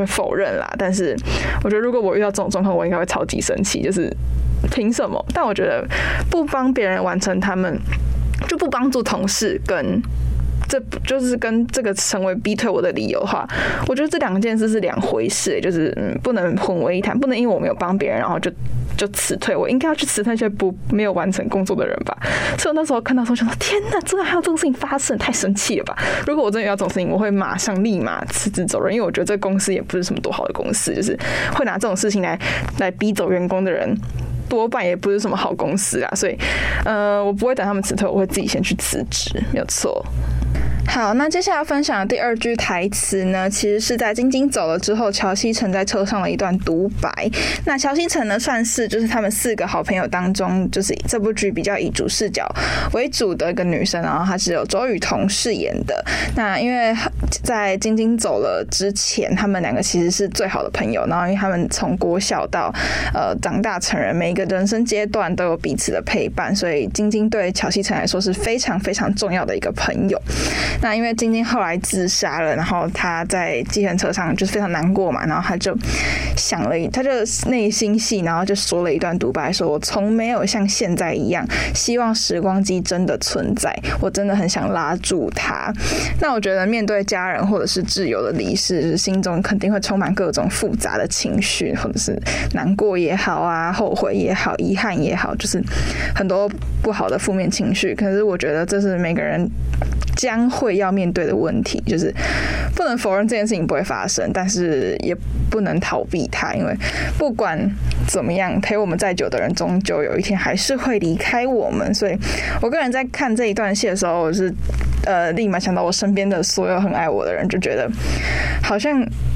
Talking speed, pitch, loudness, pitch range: 315 characters per minute, 200 Hz, -19 LUFS, 180-225 Hz